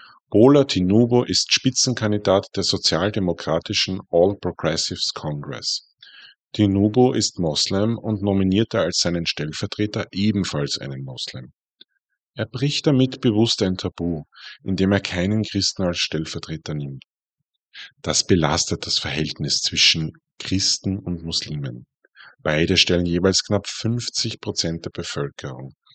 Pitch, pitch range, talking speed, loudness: 95 Hz, 85-110 Hz, 115 wpm, -21 LUFS